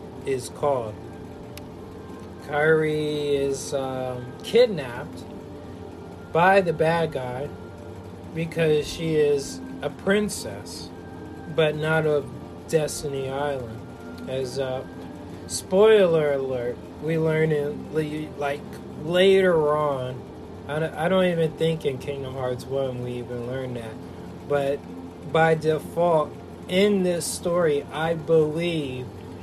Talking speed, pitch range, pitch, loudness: 110 wpm, 115-160 Hz, 145 Hz, -24 LUFS